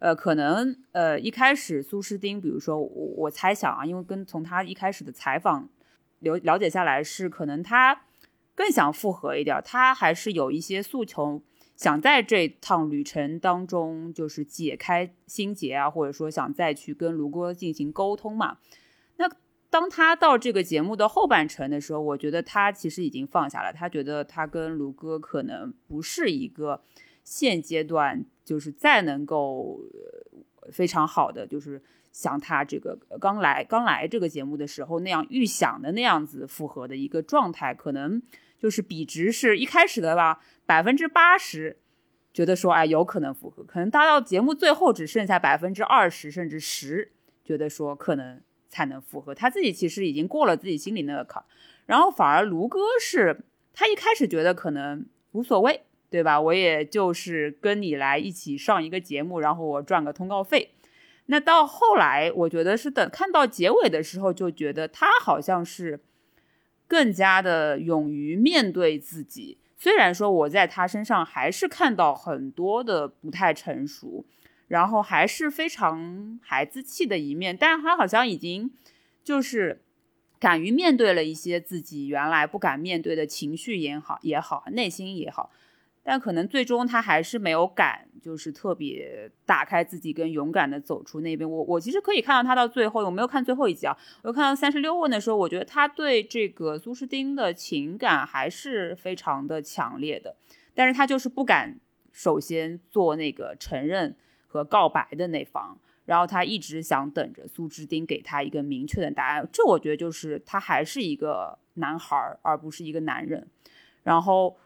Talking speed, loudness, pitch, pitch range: 270 characters per minute, -24 LUFS, 180 Hz, 155-255 Hz